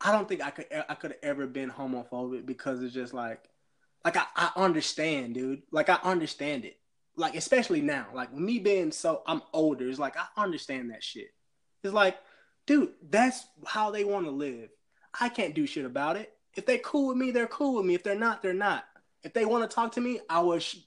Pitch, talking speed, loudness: 185 Hz, 225 wpm, -30 LUFS